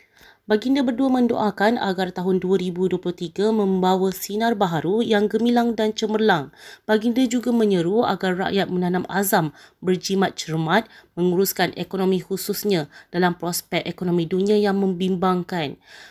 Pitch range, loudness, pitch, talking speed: 180-215 Hz, -21 LUFS, 190 Hz, 115 wpm